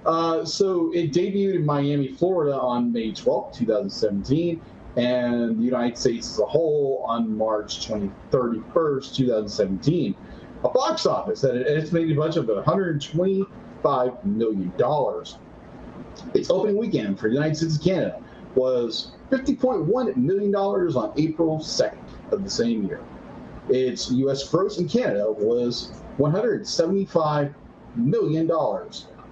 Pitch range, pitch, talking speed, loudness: 120-180 Hz, 155 Hz, 120 wpm, -23 LUFS